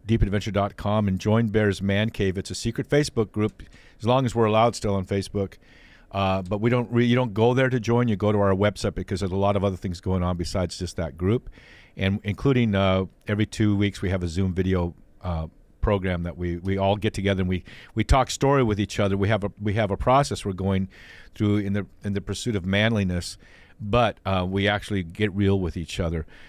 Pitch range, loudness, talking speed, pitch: 95-110 Hz, -24 LUFS, 230 wpm, 100 Hz